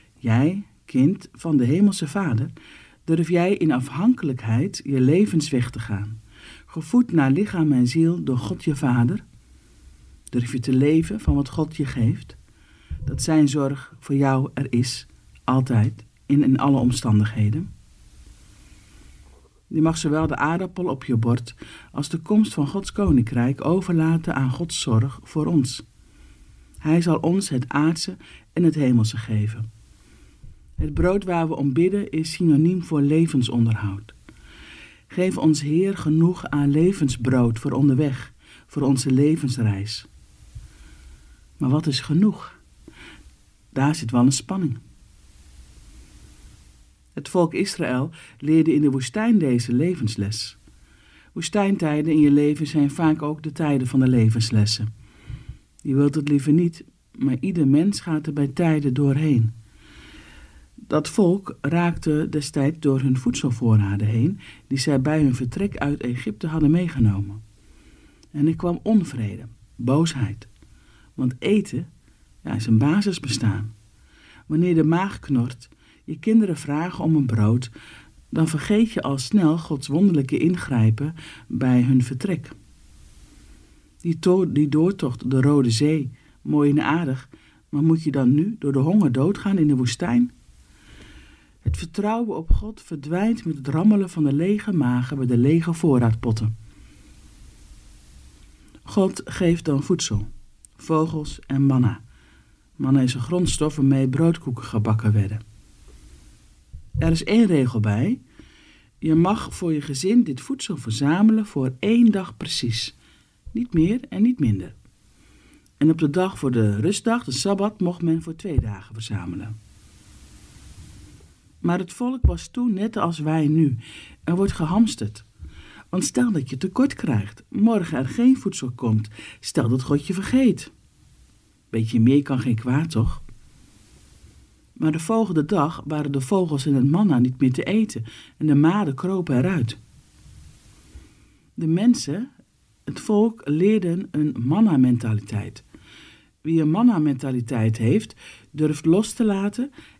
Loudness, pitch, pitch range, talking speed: -22 LUFS, 140 Hz, 115-165 Hz, 140 wpm